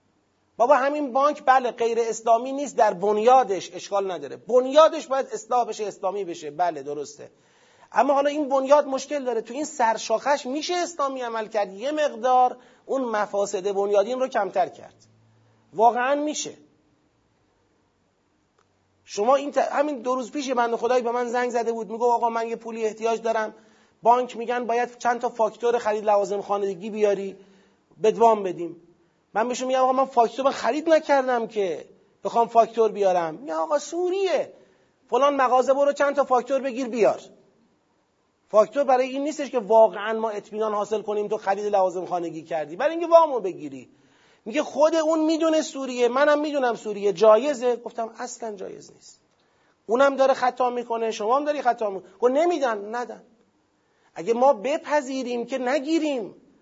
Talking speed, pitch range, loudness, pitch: 155 wpm, 210-275 Hz, -23 LUFS, 240 Hz